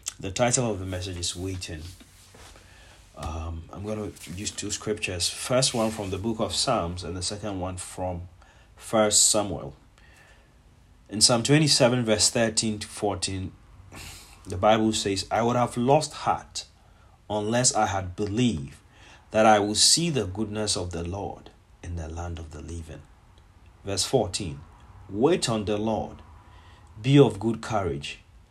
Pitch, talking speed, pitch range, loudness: 100 Hz, 150 wpm, 90-110 Hz, -24 LUFS